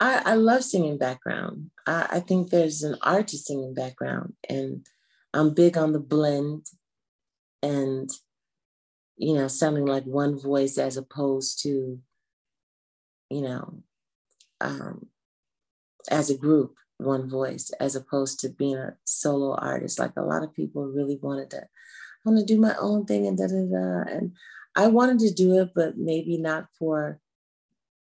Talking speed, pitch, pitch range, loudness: 155 wpm, 140 Hz, 130-165 Hz, -25 LUFS